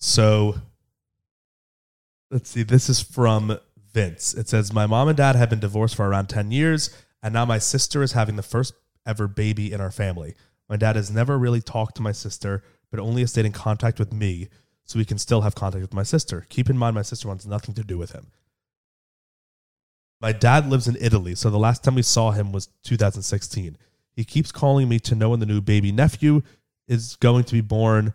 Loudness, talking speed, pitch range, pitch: -22 LUFS, 215 wpm, 105-120 Hz, 110 Hz